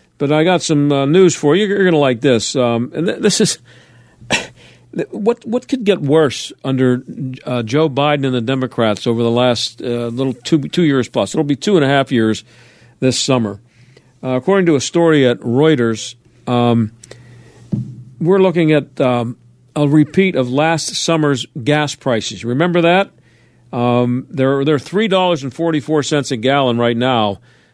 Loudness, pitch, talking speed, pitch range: -15 LUFS, 135 Hz, 175 wpm, 120-155 Hz